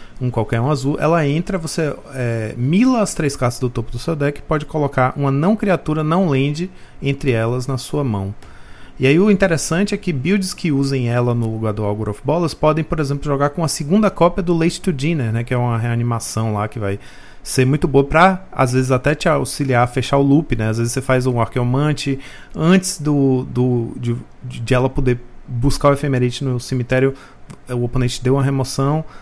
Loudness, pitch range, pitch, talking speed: -18 LUFS, 125-155 Hz, 135 Hz, 210 wpm